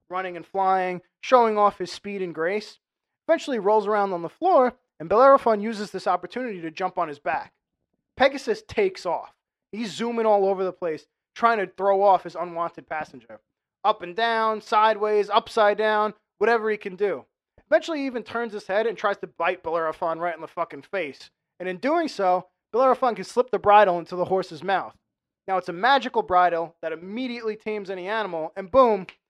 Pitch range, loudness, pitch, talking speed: 180-230 Hz, -24 LUFS, 205 Hz, 190 wpm